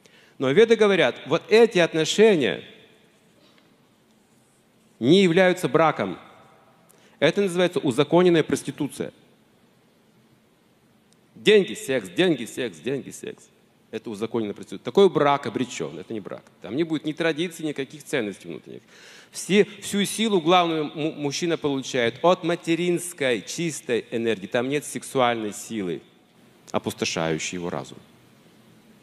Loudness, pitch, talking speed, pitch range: -23 LUFS, 155 Hz, 110 wpm, 125-180 Hz